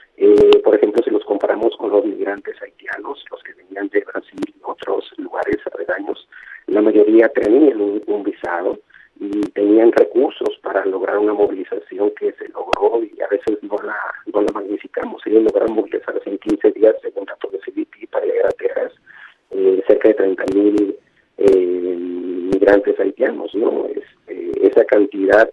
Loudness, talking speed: -17 LUFS, 160 wpm